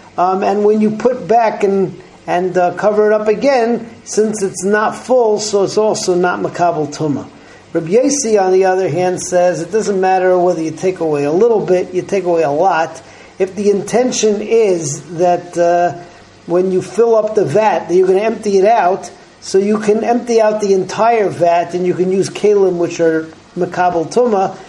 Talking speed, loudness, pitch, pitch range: 195 wpm, -14 LUFS, 190 Hz, 180-215 Hz